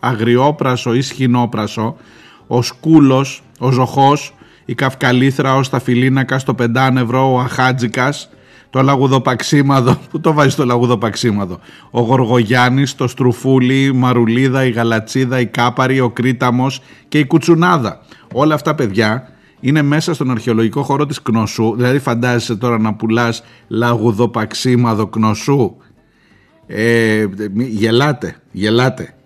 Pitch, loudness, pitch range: 125 Hz, -14 LUFS, 115-135 Hz